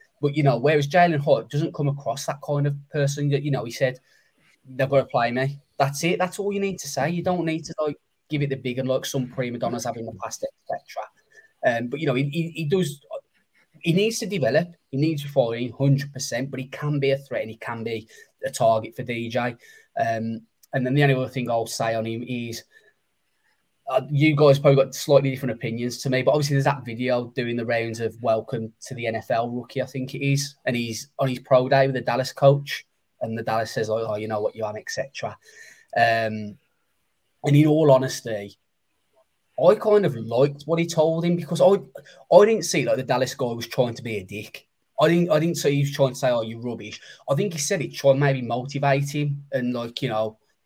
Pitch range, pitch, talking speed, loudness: 120-150 Hz, 135 Hz, 230 wpm, -23 LUFS